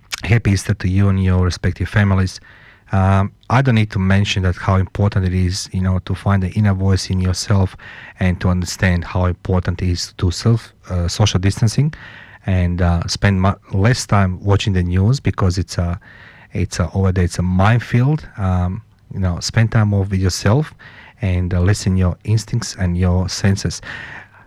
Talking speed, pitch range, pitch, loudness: 185 wpm, 90-105 Hz, 95 Hz, -18 LUFS